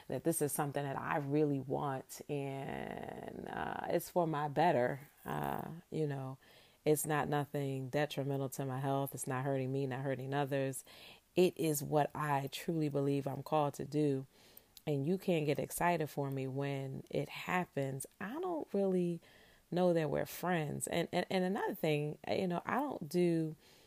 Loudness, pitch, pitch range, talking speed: -37 LUFS, 145 Hz, 135-170 Hz, 170 wpm